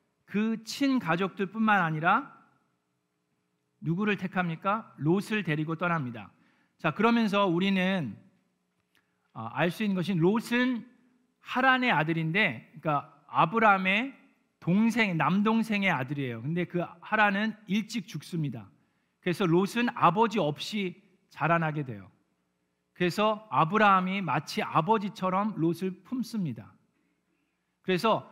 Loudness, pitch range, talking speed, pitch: -28 LUFS, 155-215 Hz, 260 characters per minute, 185 Hz